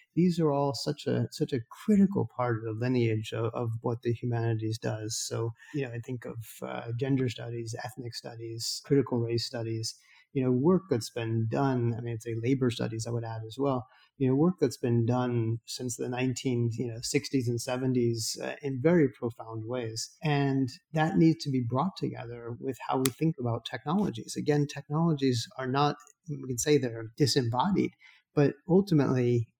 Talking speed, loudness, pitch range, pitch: 185 wpm, -30 LUFS, 115-140 Hz, 125 Hz